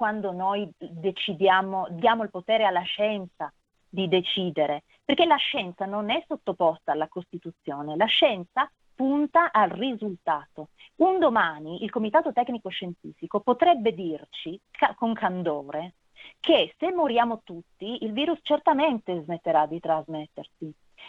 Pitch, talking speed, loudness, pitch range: 195 Hz, 120 wpm, -25 LUFS, 170-250 Hz